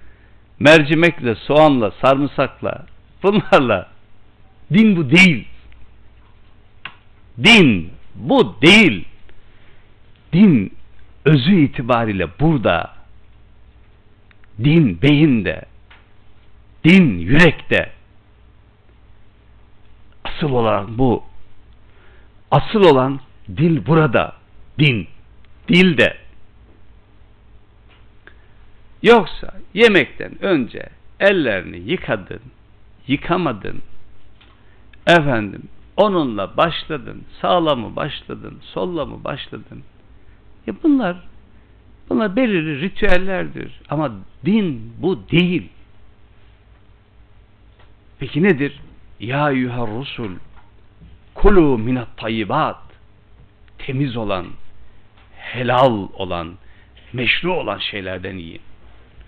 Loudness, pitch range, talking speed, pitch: -16 LUFS, 105-140 Hz, 70 wpm, 105 Hz